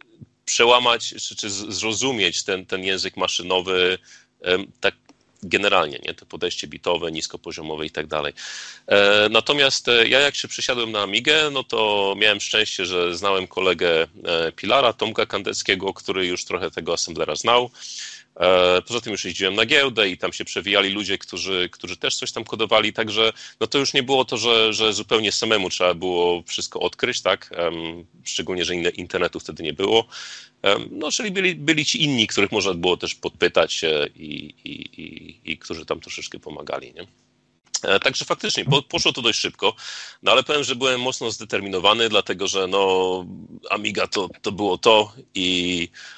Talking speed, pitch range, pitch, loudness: 160 wpm, 90-125 Hz, 100 Hz, -20 LUFS